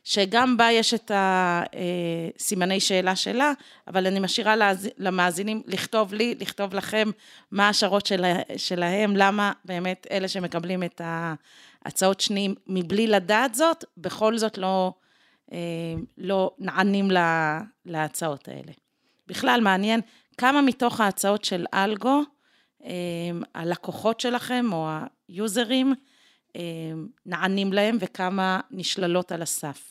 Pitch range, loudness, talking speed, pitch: 180-220 Hz, -24 LUFS, 110 wpm, 195 Hz